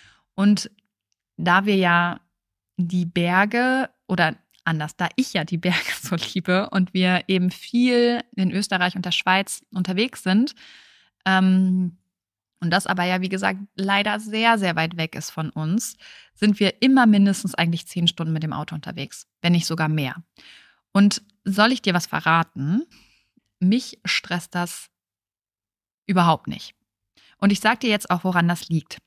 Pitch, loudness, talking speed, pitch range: 185 Hz, -21 LUFS, 155 wpm, 165-205 Hz